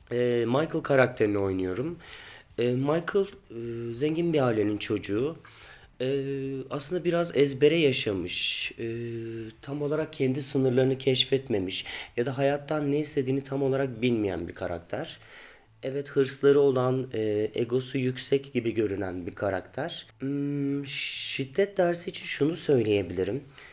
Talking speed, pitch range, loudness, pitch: 105 wpm, 115-140 Hz, -28 LUFS, 135 Hz